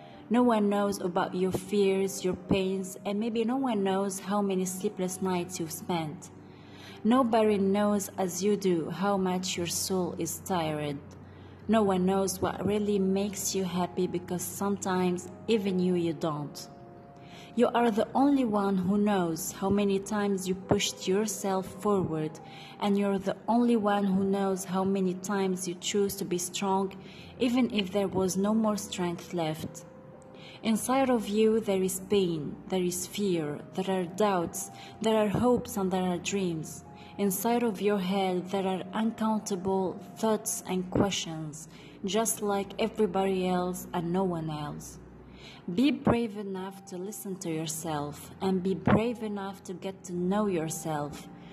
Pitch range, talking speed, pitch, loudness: 180-205 Hz, 155 wpm, 195 Hz, -29 LUFS